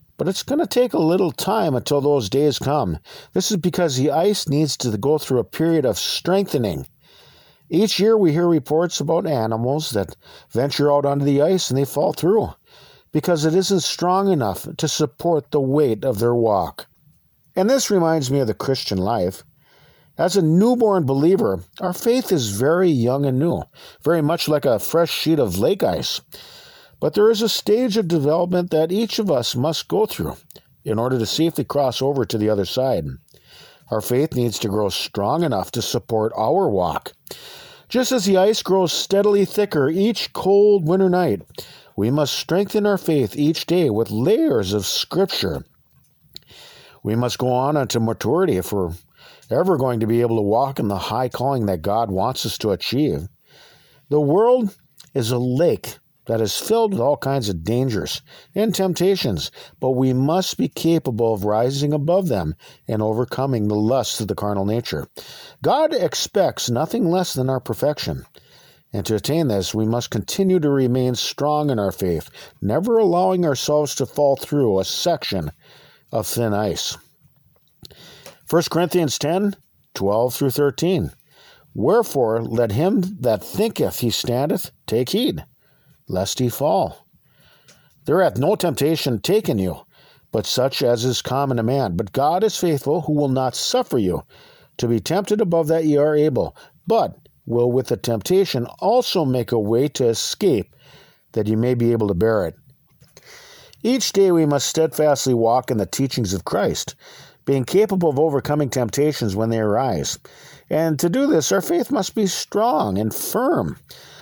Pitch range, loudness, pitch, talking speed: 120-180 Hz, -20 LUFS, 145 Hz, 170 wpm